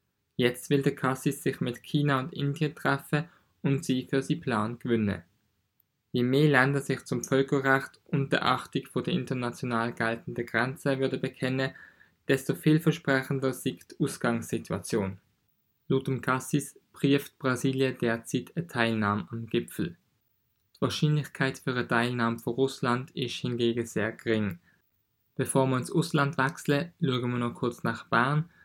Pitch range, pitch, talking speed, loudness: 120-140 Hz, 130 Hz, 140 wpm, -29 LUFS